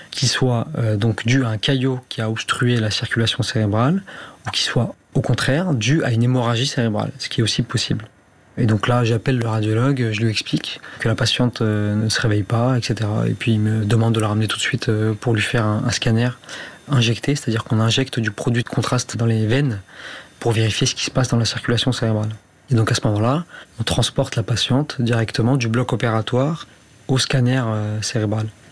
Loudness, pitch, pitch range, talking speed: -19 LUFS, 115 Hz, 110-130 Hz, 215 wpm